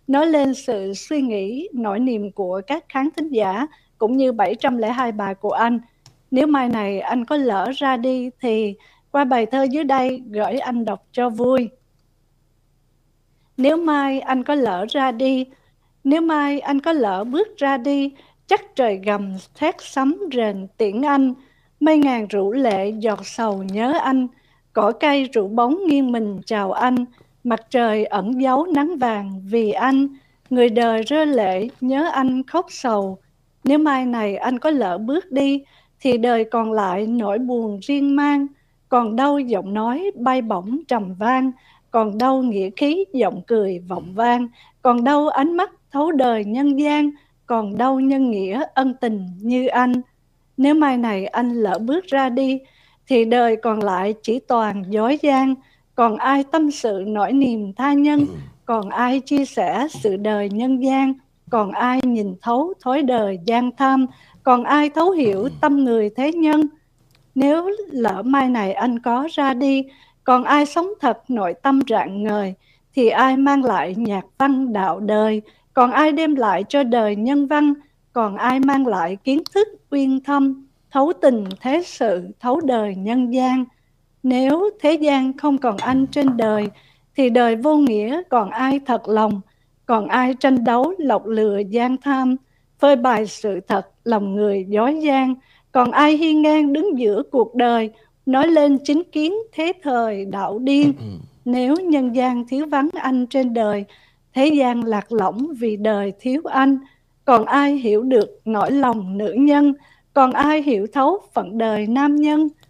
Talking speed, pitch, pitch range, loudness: 170 wpm, 255 Hz, 220-280 Hz, -19 LUFS